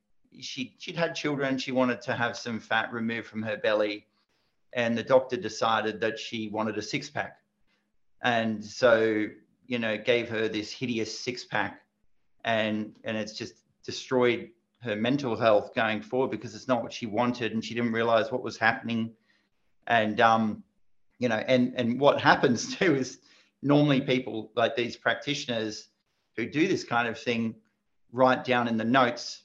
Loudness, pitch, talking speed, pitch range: -28 LUFS, 115 Hz, 170 wpm, 110-125 Hz